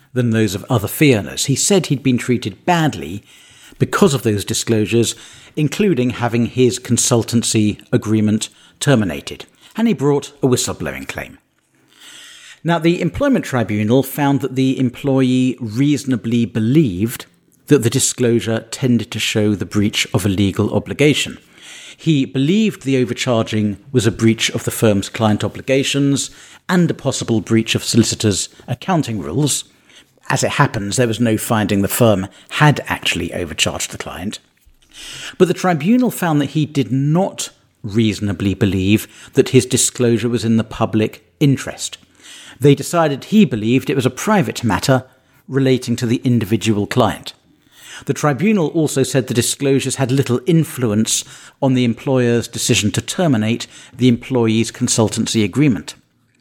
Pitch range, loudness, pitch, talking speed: 110-140 Hz, -17 LUFS, 125 Hz, 145 wpm